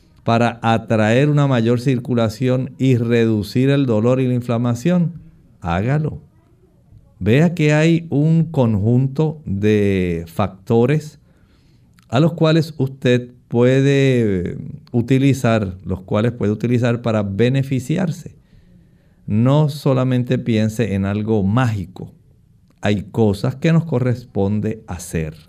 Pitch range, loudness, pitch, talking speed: 110-140 Hz, -18 LUFS, 125 Hz, 105 wpm